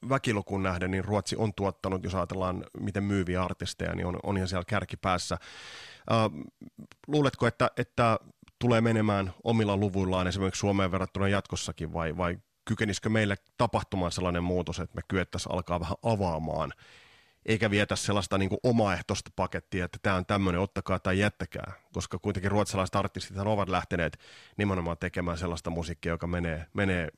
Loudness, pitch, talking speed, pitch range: -30 LUFS, 95 Hz, 150 wpm, 90-105 Hz